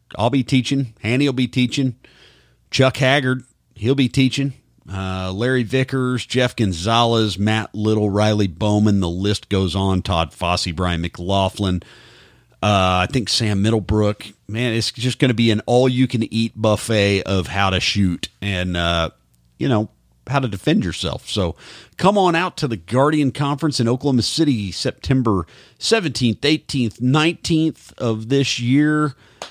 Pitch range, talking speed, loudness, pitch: 100-130 Hz, 145 wpm, -19 LUFS, 115 Hz